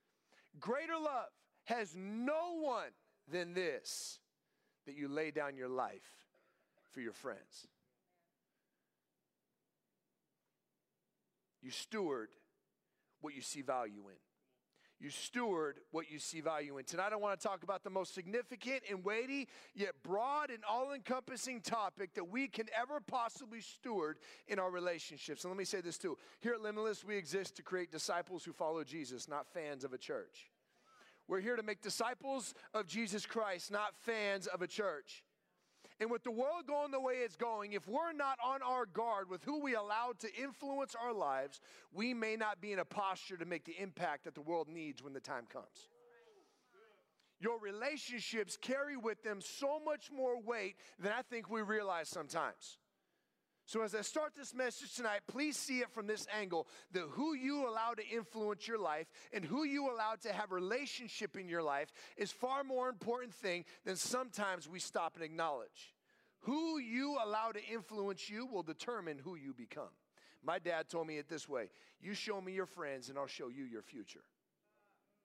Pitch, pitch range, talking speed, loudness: 215 Hz, 180-255 Hz, 175 wpm, -42 LUFS